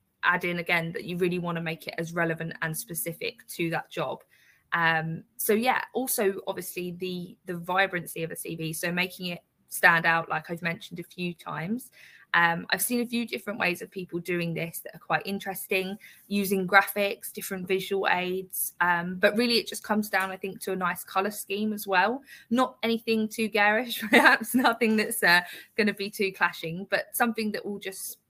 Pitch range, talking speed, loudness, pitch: 175-215 Hz, 195 wpm, -27 LUFS, 190 Hz